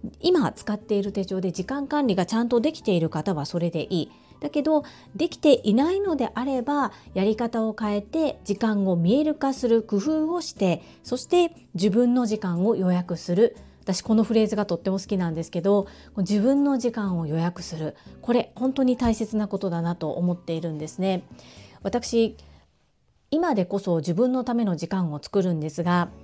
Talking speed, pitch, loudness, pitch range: 350 characters per minute, 210 Hz, -25 LUFS, 180-250 Hz